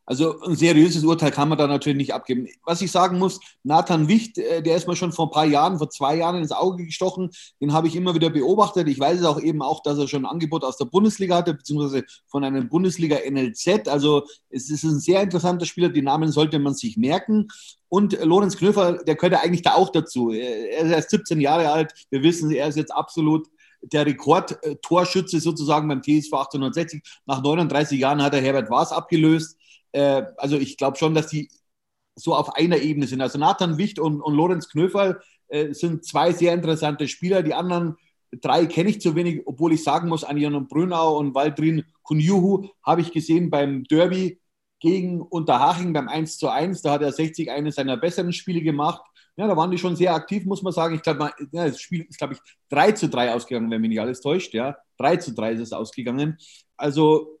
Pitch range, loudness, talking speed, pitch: 145-175 Hz, -22 LUFS, 205 wpm, 160 Hz